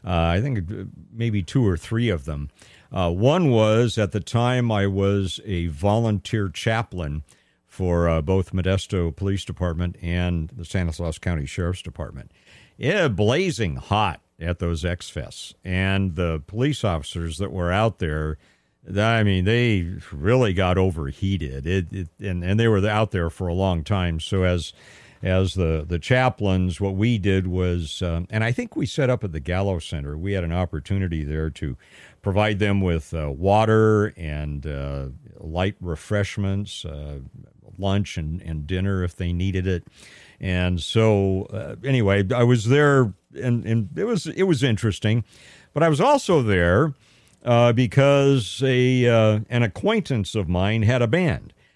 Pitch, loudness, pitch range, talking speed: 95 Hz, -22 LUFS, 85-110 Hz, 160 wpm